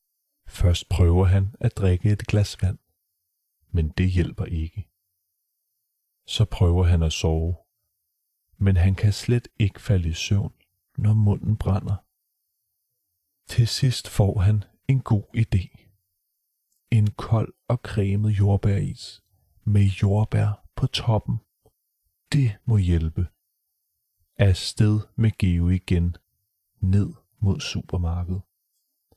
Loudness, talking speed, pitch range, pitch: -23 LUFS, 110 wpm, 90-105 Hz, 100 Hz